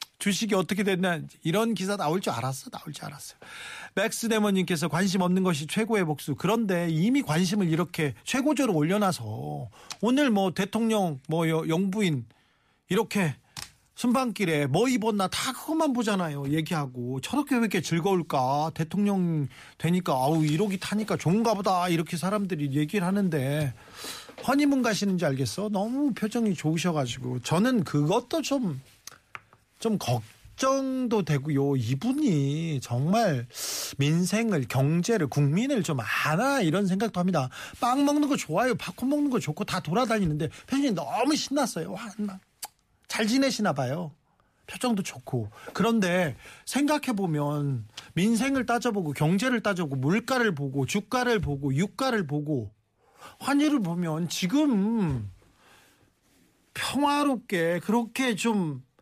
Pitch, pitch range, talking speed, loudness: 185 Hz, 150-225 Hz, 295 characters per minute, -27 LUFS